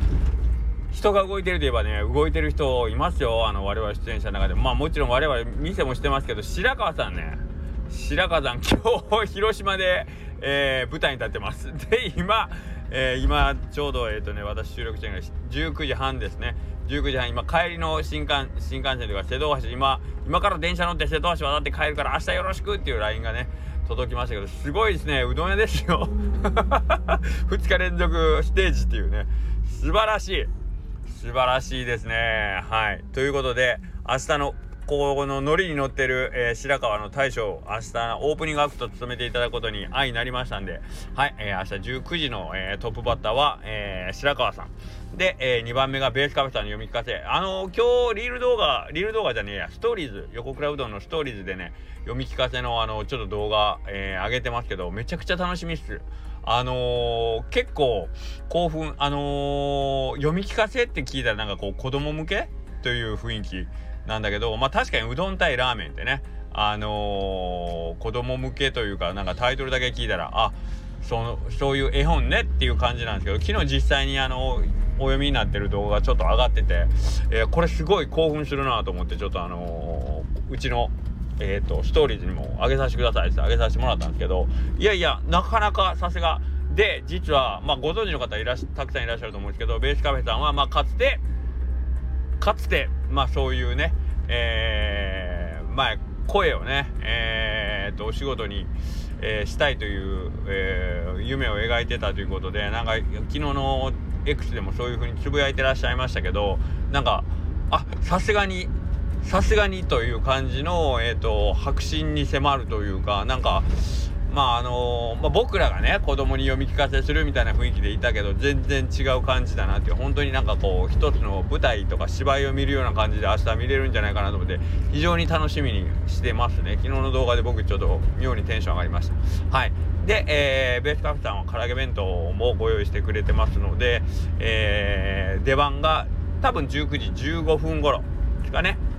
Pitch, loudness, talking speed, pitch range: 85 Hz, -24 LUFS, 390 characters per minute, 75-120 Hz